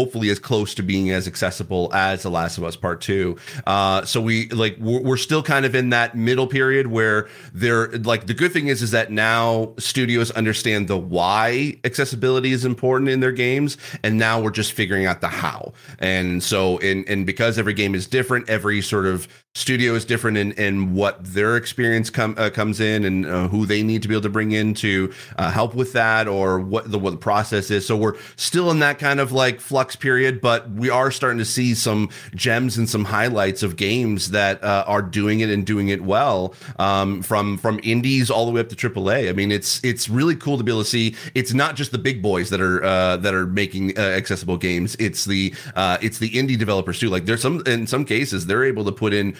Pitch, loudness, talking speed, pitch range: 110 Hz, -20 LUFS, 230 wpm, 100-125 Hz